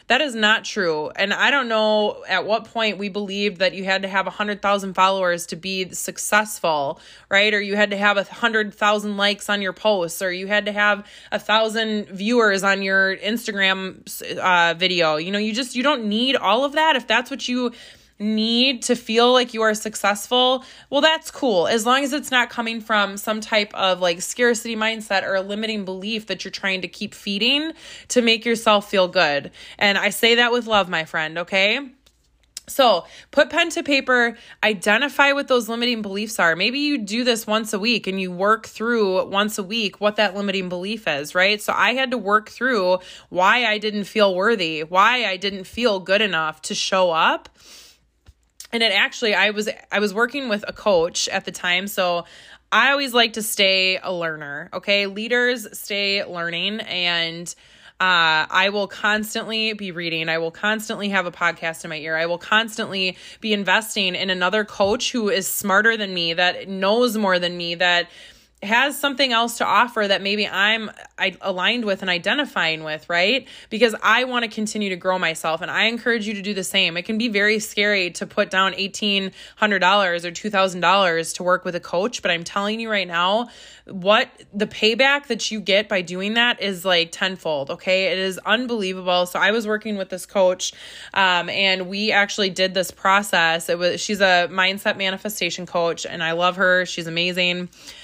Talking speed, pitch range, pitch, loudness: 195 wpm, 185-220 Hz, 205 Hz, -20 LUFS